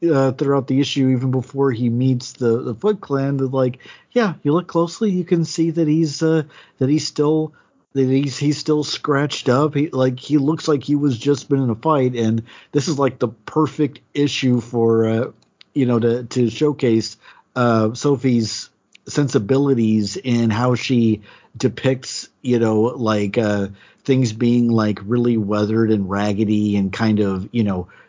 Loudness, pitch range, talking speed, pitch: -19 LUFS, 115-145 Hz, 175 wpm, 130 Hz